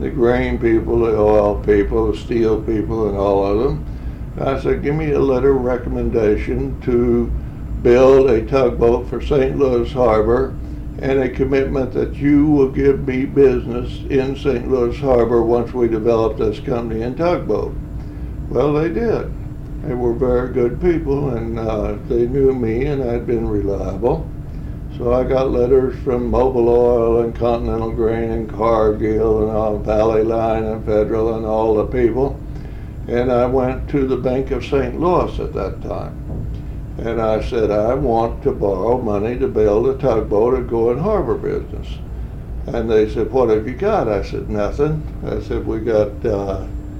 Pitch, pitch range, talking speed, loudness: 120 Hz, 110-130 Hz, 170 wpm, -18 LUFS